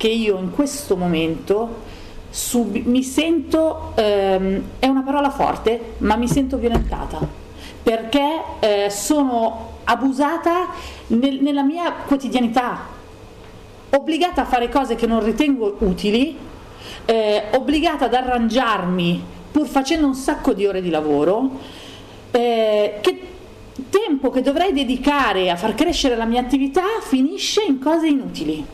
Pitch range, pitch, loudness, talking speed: 220-290 Hz, 255 Hz, -19 LUFS, 125 wpm